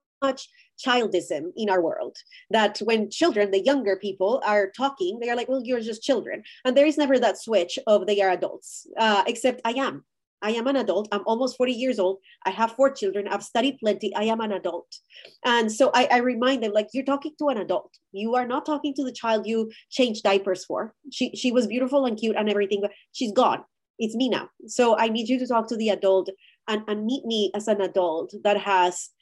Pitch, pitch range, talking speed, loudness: 230 Hz, 205-260 Hz, 225 wpm, -24 LUFS